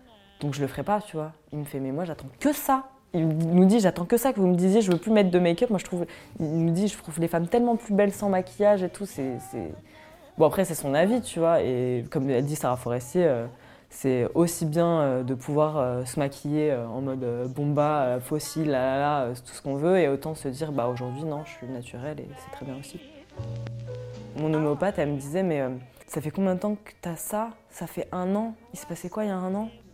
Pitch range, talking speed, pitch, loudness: 135-185 Hz, 250 wpm, 155 Hz, -26 LUFS